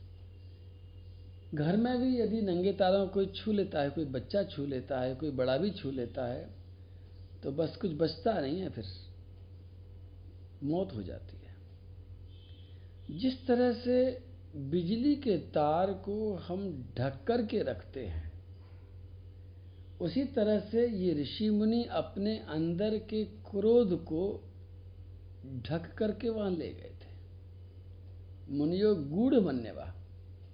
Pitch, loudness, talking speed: 130 Hz, -33 LUFS, 130 wpm